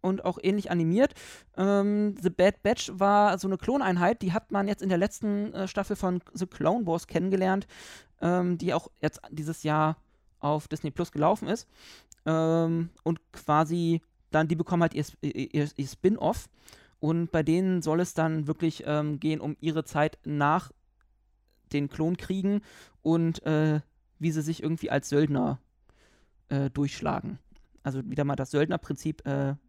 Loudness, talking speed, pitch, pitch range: -28 LUFS, 160 wpm, 160 Hz, 150-185 Hz